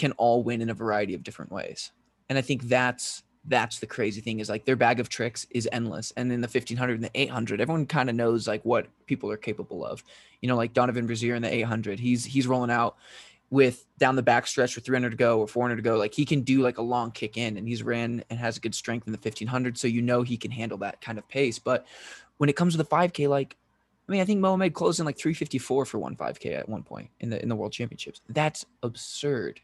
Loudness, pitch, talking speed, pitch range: -27 LUFS, 120 Hz, 260 wpm, 115-130 Hz